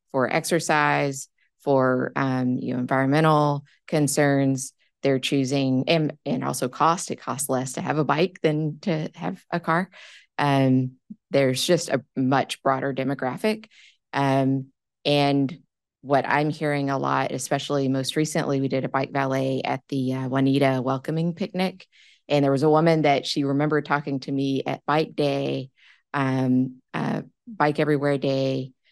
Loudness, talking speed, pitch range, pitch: -24 LUFS, 150 wpm, 135-150 Hz, 140 Hz